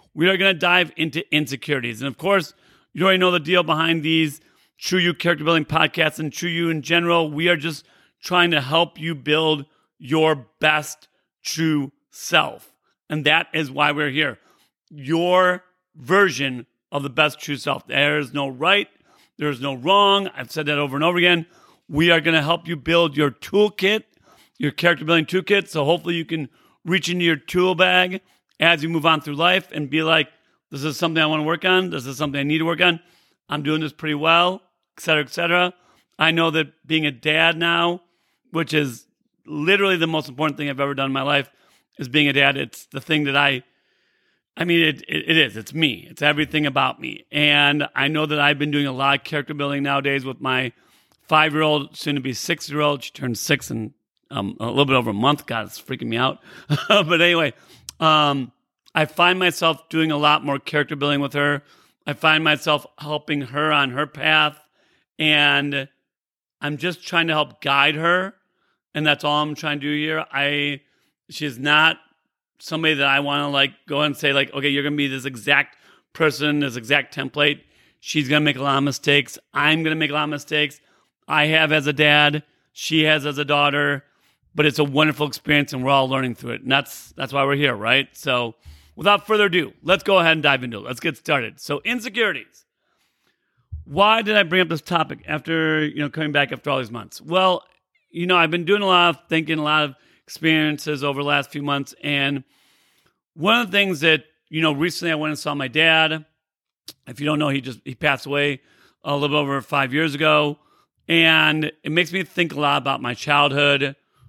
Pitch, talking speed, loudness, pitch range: 150 Hz, 210 wpm, -19 LUFS, 145-165 Hz